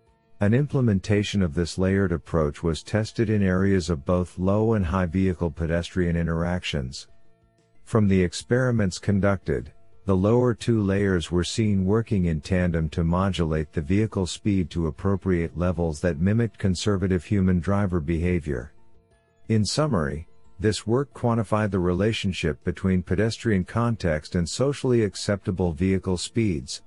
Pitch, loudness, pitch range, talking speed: 95 Hz, -24 LUFS, 85-110 Hz, 135 wpm